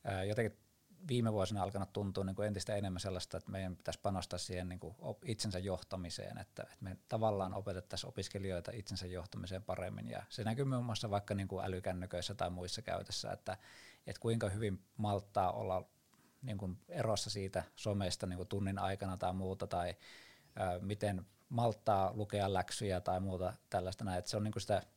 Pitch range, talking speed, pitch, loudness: 95-105 Hz, 165 wpm, 100 Hz, -40 LUFS